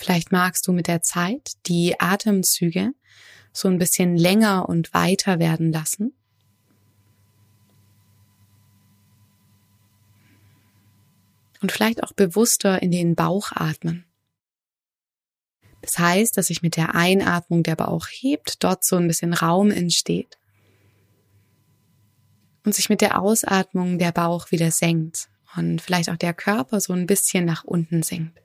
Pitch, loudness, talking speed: 170 Hz, -21 LUFS, 125 wpm